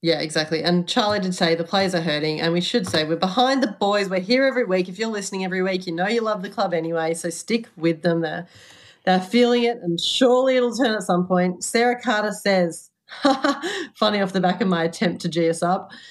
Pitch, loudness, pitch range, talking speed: 190 Hz, -21 LUFS, 170-235 Hz, 235 wpm